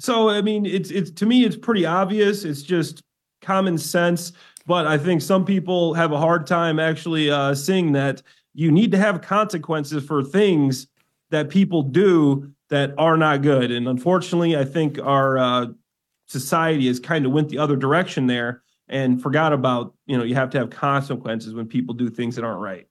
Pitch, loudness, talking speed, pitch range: 155 Hz, -20 LUFS, 190 wpm, 135-175 Hz